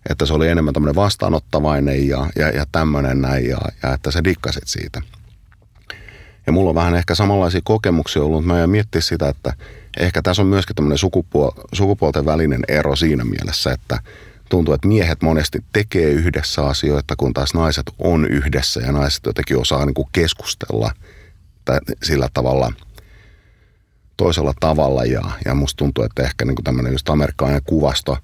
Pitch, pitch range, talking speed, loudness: 80 Hz, 70-90 Hz, 170 wpm, -18 LUFS